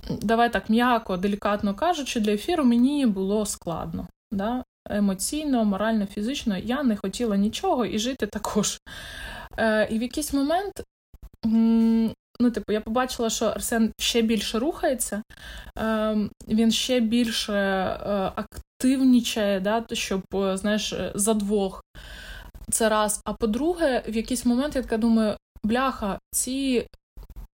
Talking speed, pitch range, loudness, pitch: 125 wpm, 210-245 Hz, -24 LUFS, 225 Hz